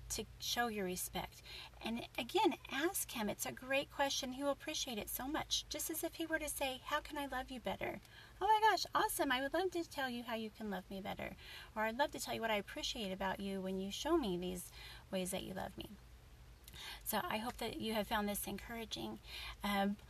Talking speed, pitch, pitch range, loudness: 235 wpm, 240 Hz, 195-300 Hz, -40 LUFS